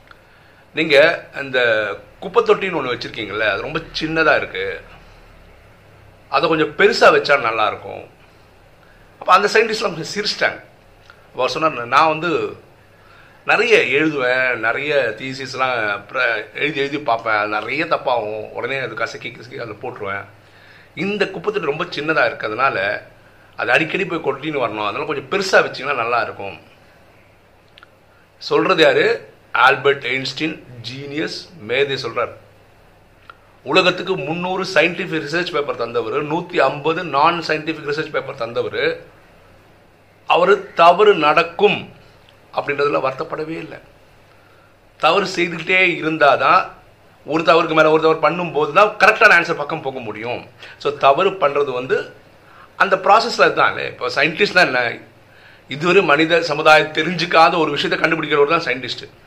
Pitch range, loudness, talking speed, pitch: 135-195 Hz, -17 LUFS, 120 wpm, 160 Hz